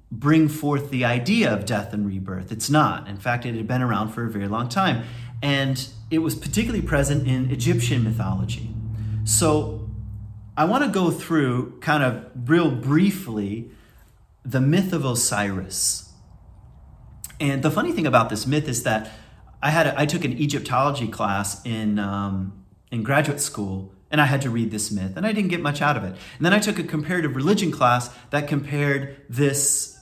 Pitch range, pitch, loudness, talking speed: 110-150 Hz, 125 Hz, -22 LUFS, 180 wpm